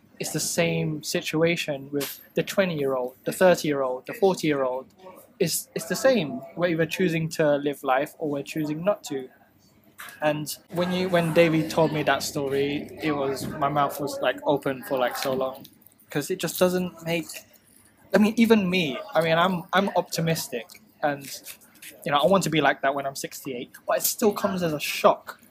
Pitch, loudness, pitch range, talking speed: 160 Hz, -25 LUFS, 140-180 Hz, 185 wpm